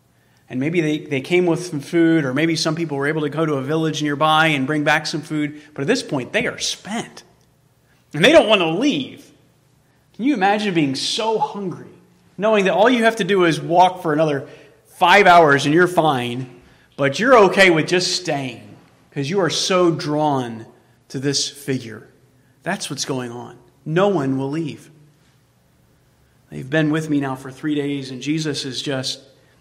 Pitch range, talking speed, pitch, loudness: 140-175 Hz, 190 wpm, 150 Hz, -18 LUFS